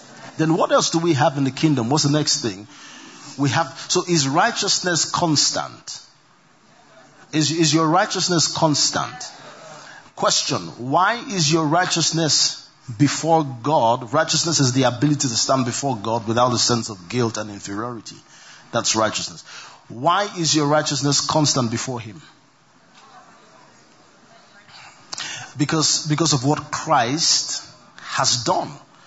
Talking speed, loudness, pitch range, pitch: 130 wpm, -19 LUFS, 130-165 Hz, 150 Hz